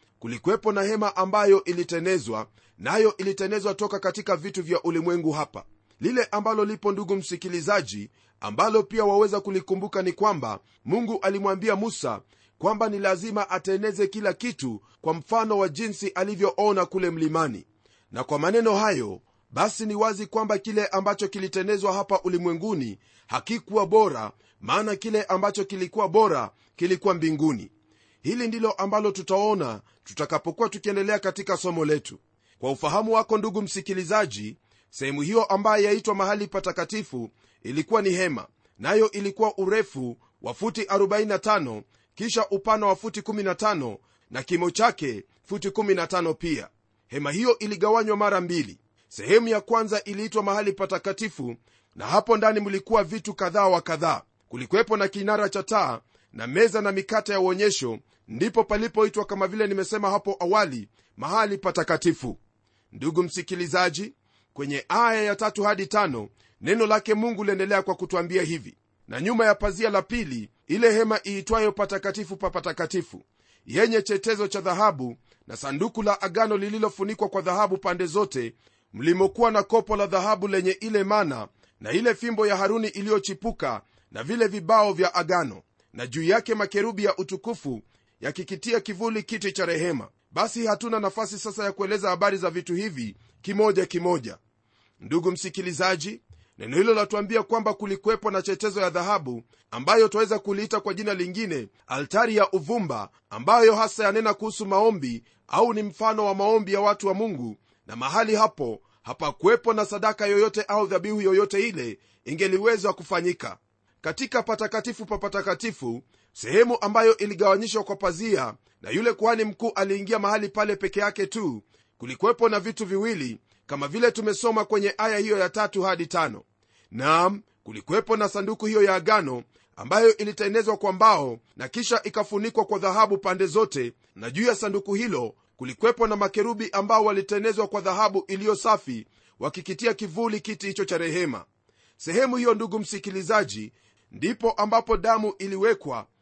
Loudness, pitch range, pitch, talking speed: -24 LUFS, 175-215 Hz, 200 Hz, 140 wpm